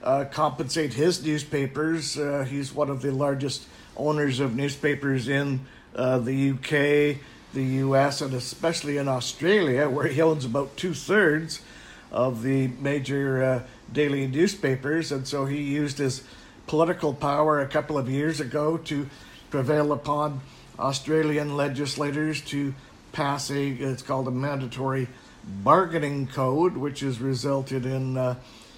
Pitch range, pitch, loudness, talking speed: 135-150 Hz, 140 Hz, -26 LUFS, 135 wpm